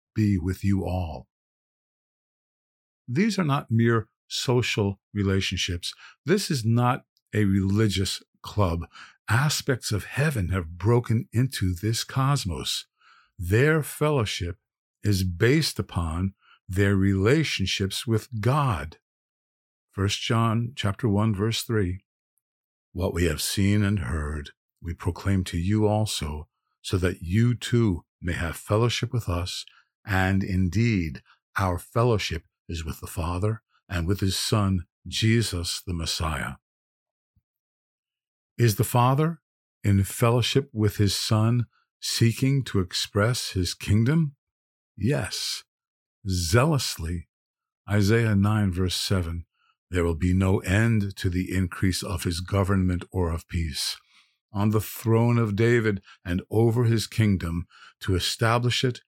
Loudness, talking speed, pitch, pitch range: -25 LUFS, 120 wpm, 100 Hz, 90-115 Hz